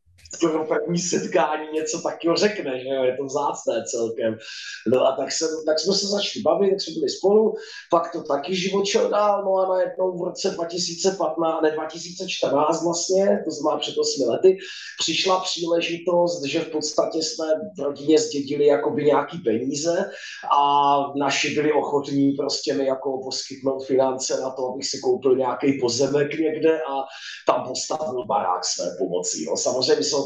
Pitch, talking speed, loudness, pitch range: 155 Hz, 165 wpm, -22 LUFS, 140-180 Hz